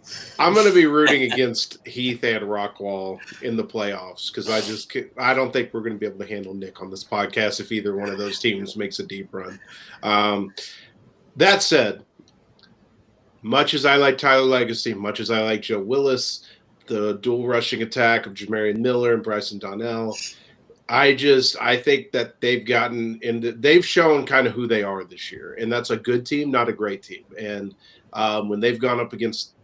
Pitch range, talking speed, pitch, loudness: 105-125 Hz, 195 wpm, 115 Hz, -21 LUFS